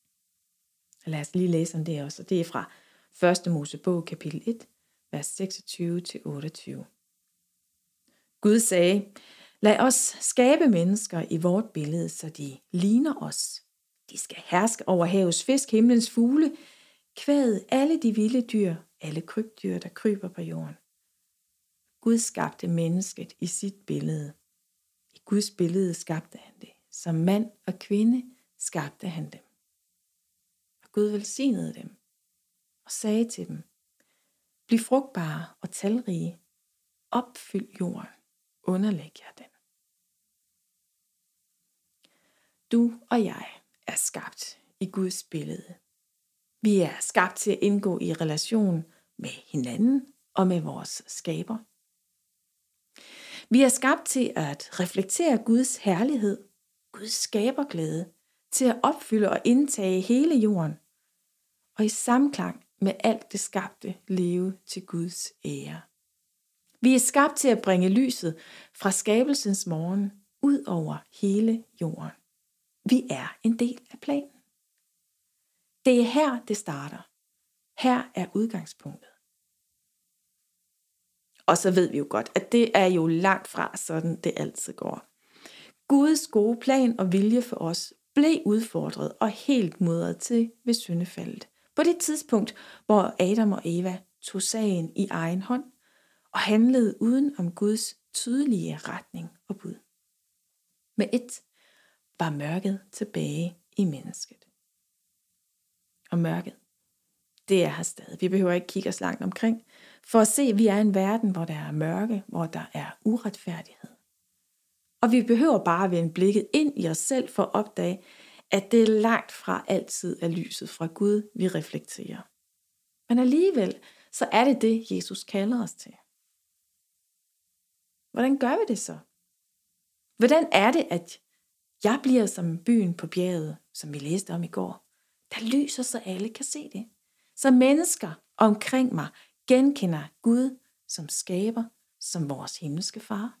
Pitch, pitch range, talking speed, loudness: 205 Hz, 175-235 Hz, 135 wpm, -26 LUFS